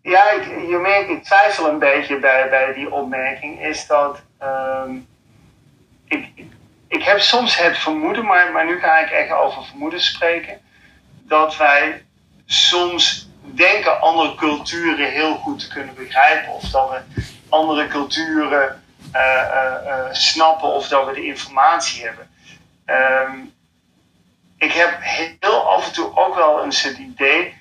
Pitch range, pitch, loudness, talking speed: 130-170 Hz, 150 Hz, -16 LUFS, 150 wpm